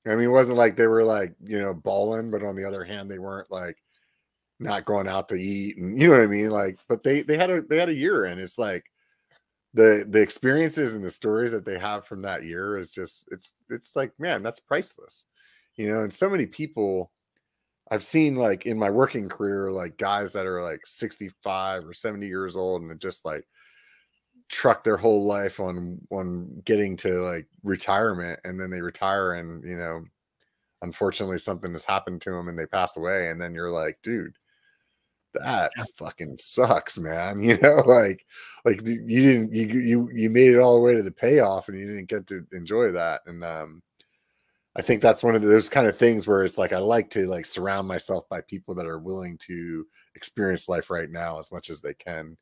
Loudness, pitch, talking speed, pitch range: -24 LUFS, 100 Hz, 210 wpm, 90-115 Hz